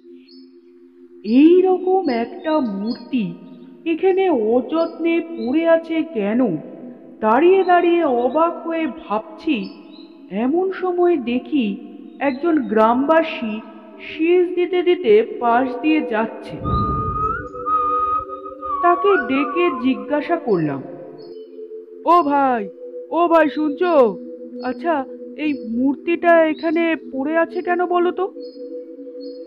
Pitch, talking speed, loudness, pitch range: 315 Hz, 85 wpm, -18 LUFS, 250-355 Hz